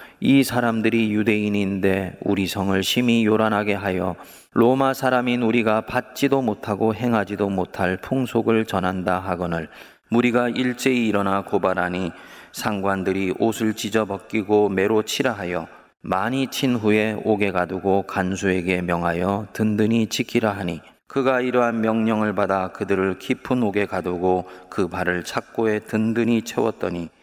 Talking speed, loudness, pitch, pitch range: 305 characters per minute, -22 LUFS, 105 Hz, 95-115 Hz